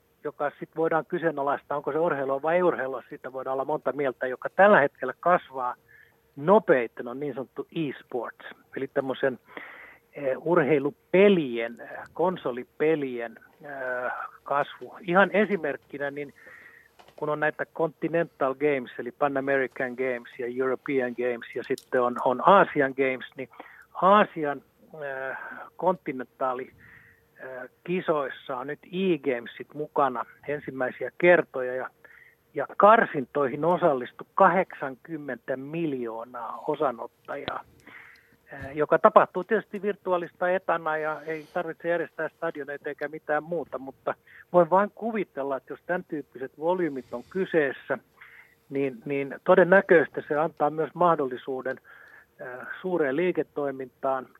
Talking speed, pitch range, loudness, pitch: 110 wpm, 130-170 Hz, -26 LUFS, 145 Hz